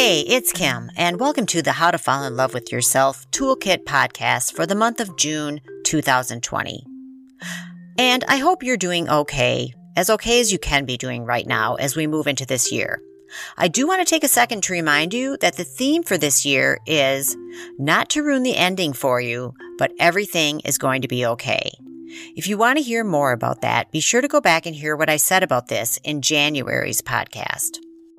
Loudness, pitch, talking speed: -19 LUFS, 155 Hz, 205 wpm